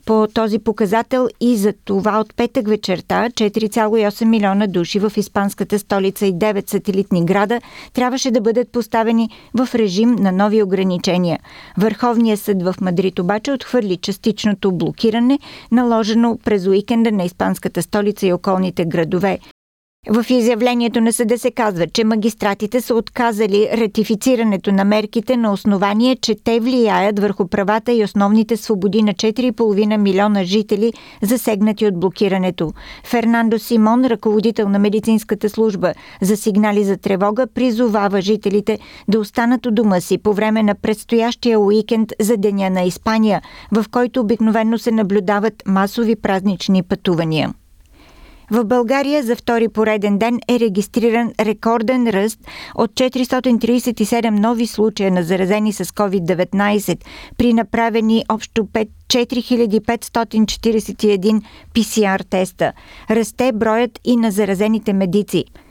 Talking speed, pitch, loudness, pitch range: 125 wpm, 220 Hz, -17 LUFS, 200-230 Hz